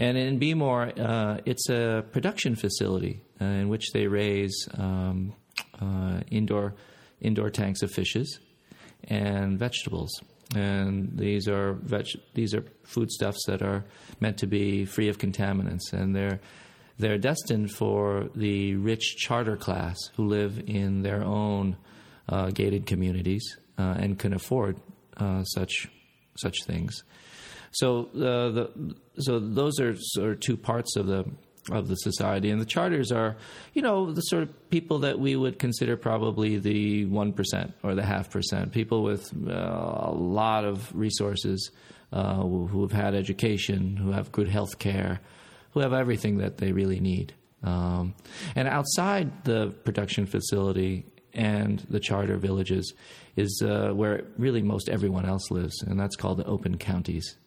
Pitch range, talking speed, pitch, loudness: 95-115 Hz, 155 wpm, 105 Hz, -28 LUFS